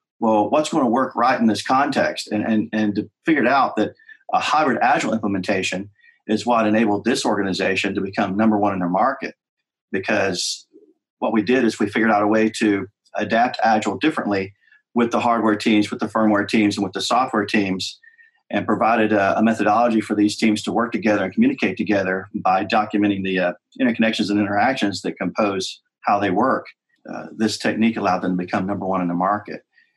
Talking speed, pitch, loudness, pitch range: 195 wpm, 105 Hz, -20 LUFS, 100-115 Hz